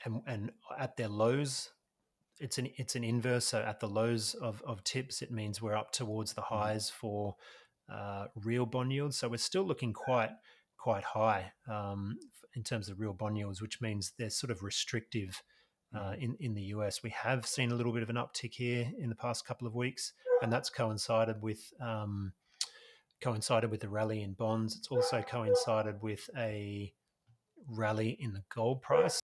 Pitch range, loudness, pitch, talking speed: 105-125 Hz, -36 LUFS, 115 Hz, 185 wpm